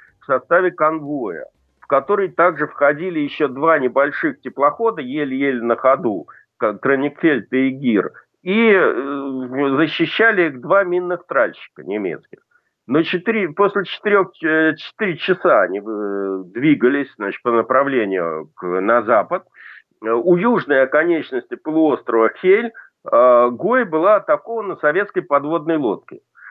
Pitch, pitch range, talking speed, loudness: 155 Hz, 135-200 Hz, 110 wpm, -18 LUFS